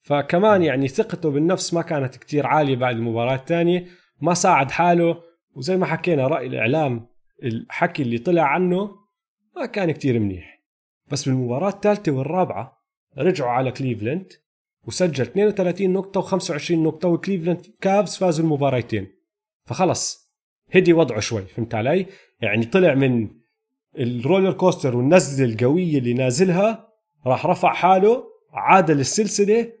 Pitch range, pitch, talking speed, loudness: 130-190 Hz, 170 Hz, 125 wpm, -20 LUFS